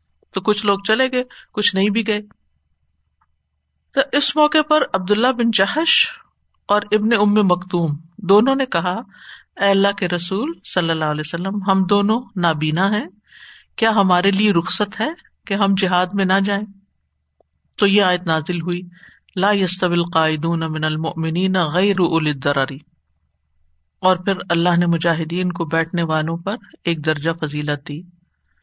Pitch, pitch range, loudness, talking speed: 180 Hz, 160-205 Hz, -18 LUFS, 145 wpm